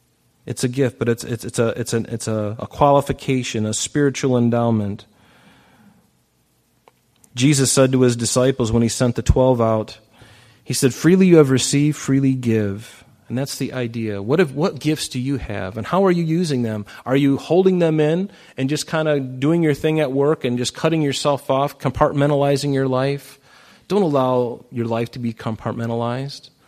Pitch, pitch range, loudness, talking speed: 130 Hz, 115-145 Hz, -19 LUFS, 185 wpm